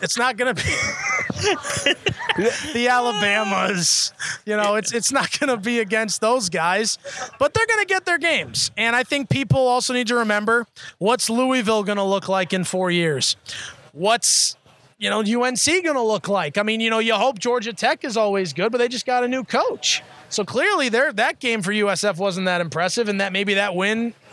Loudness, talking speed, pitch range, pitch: -20 LUFS, 190 wpm, 200-250 Hz, 225 Hz